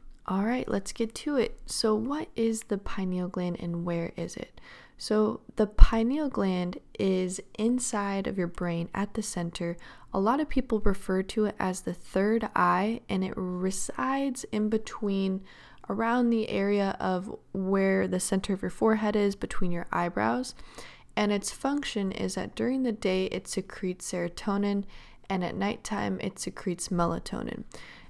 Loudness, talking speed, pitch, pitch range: -30 LUFS, 160 wpm, 200 Hz, 185-225 Hz